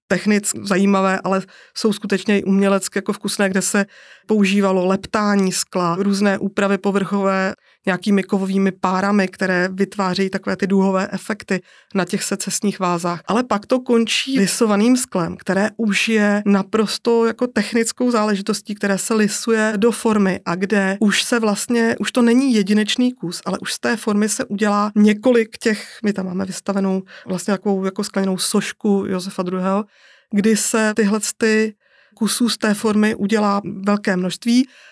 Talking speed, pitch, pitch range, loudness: 155 wpm, 205 Hz, 195-220 Hz, -18 LUFS